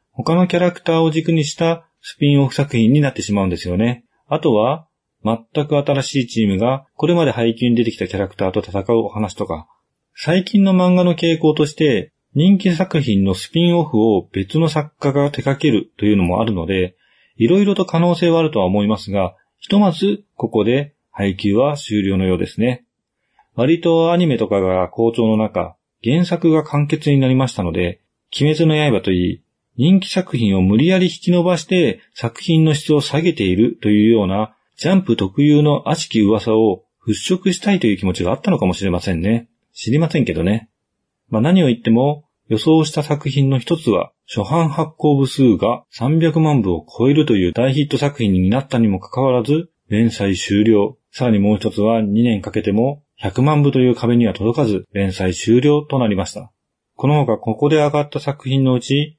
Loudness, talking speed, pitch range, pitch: -17 LUFS, 365 characters per minute, 105-155 Hz, 130 Hz